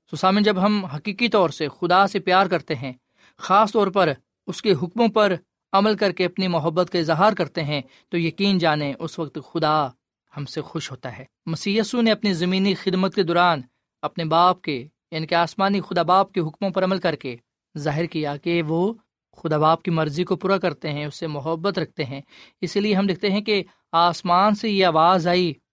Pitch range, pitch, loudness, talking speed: 155-195 Hz, 175 Hz, -21 LUFS, 205 wpm